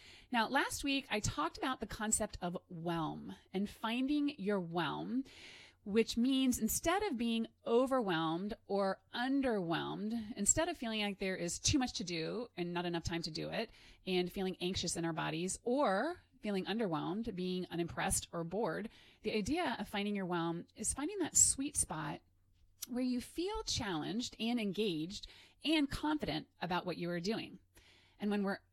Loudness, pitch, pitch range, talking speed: -37 LUFS, 210 Hz, 175-245 Hz, 165 wpm